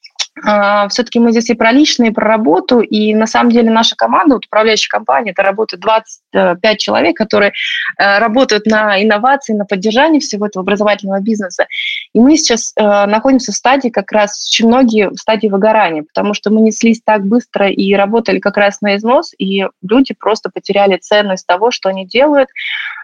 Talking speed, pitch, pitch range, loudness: 170 wpm, 220 Hz, 205-240 Hz, -11 LUFS